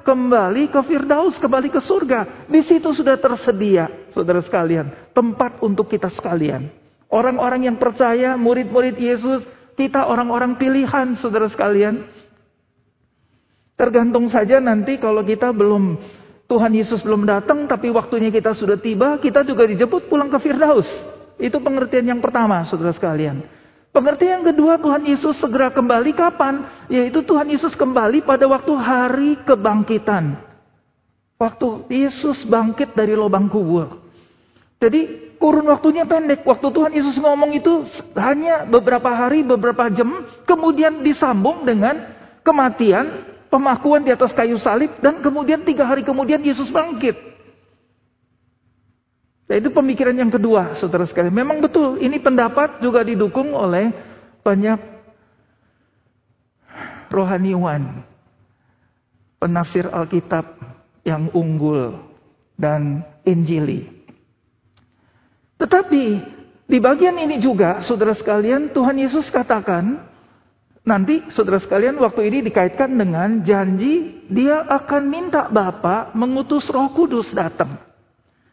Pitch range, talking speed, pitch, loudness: 195-280 Hz, 115 wpm, 245 Hz, -17 LUFS